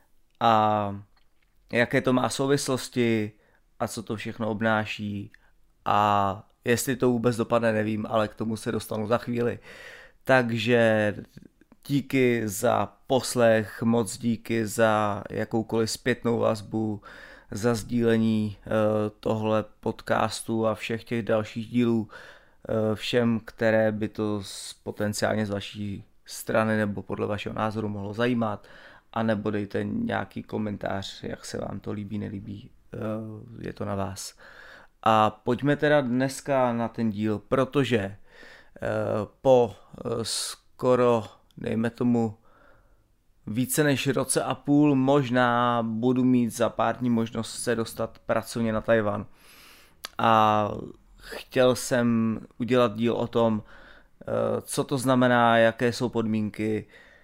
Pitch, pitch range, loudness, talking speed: 115 Hz, 110-120 Hz, -26 LUFS, 120 wpm